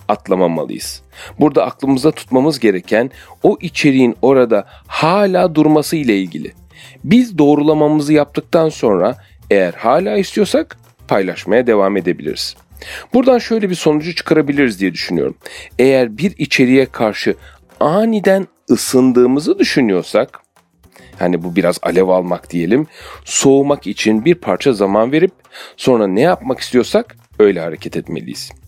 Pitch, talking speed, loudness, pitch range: 145 Hz, 115 wpm, -14 LUFS, 120-175 Hz